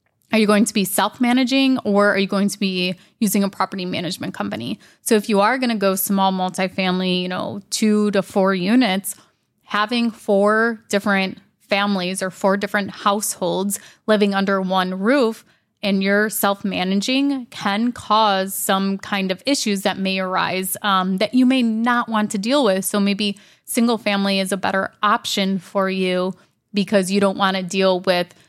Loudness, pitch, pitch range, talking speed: -19 LUFS, 200 Hz, 190-215 Hz, 175 wpm